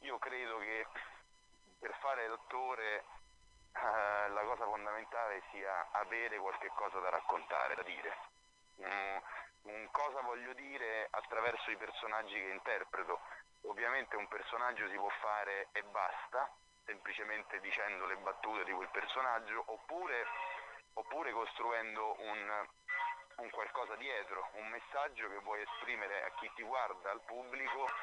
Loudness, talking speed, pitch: -41 LUFS, 130 wpm, 125 Hz